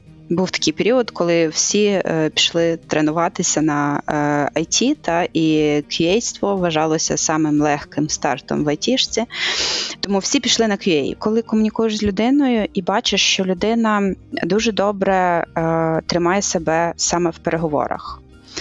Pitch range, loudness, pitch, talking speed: 160-215 Hz, -18 LUFS, 175 Hz, 130 wpm